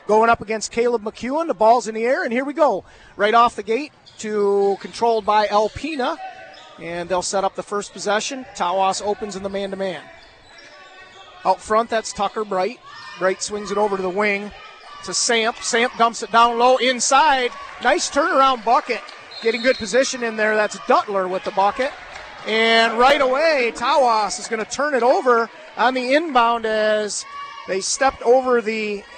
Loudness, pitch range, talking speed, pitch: -19 LUFS, 205-255 Hz, 180 wpm, 225 Hz